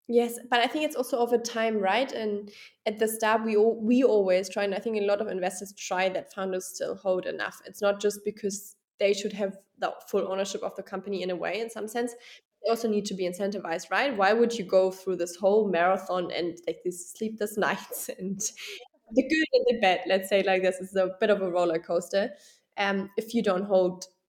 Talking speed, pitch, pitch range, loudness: 230 wpm, 200 Hz, 190-225 Hz, -28 LUFS